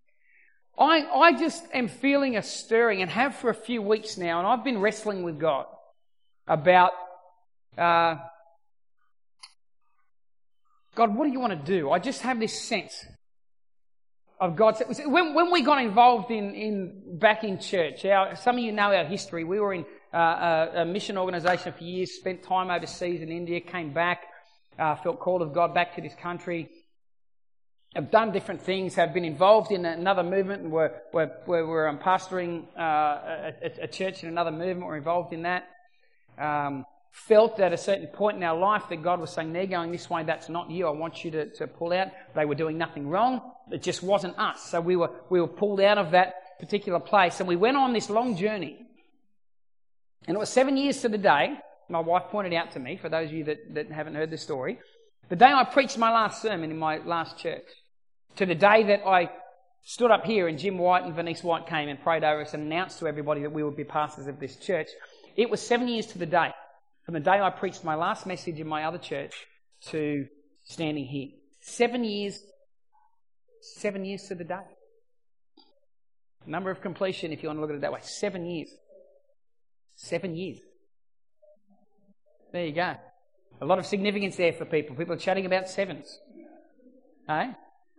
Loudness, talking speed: -26 LUFS, 195 wpm